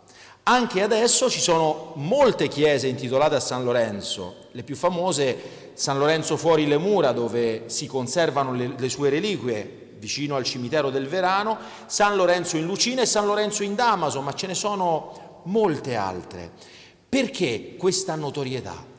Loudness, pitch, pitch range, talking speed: -23 LUFS, 150 Hz, 130-185 Hz, 150 wpm